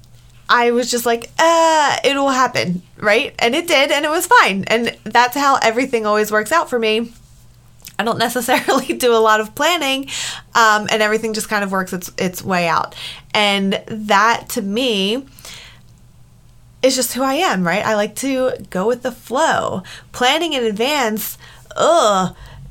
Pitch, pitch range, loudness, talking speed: 230 Hz, 200-260 Hz, -16 LUFS, 170 wpm